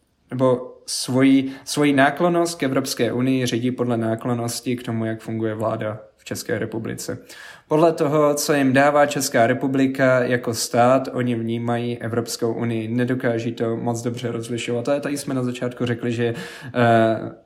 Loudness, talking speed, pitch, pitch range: -21 LUFS, 150 wpm, 125 Hz, 115-135 Hz